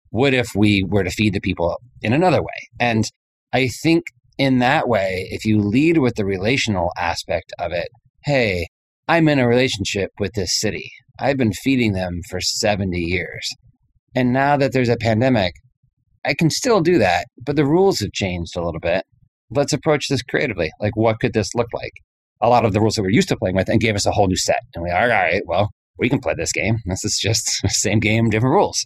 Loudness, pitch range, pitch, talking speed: -19 LUFS, 100-130 Hz, 110 Hz, 220 wpm